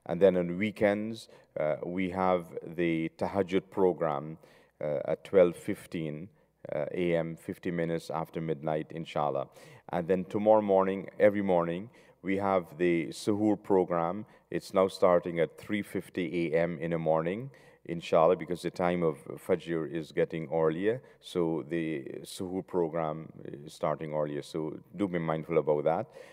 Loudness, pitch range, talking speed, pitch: -31 LUFS, 80-95 Hz, 140 wpm, 90 Hz